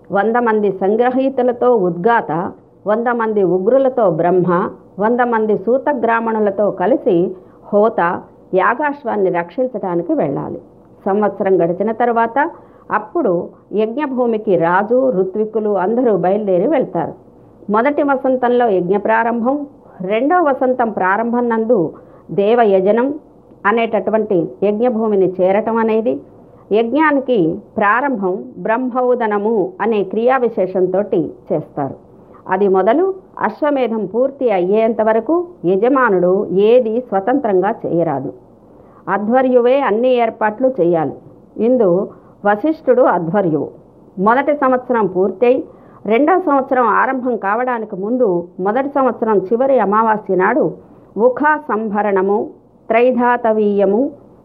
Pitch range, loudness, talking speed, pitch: 195-250 Hz, -15 LUFS, 90 wpm, 225 Hz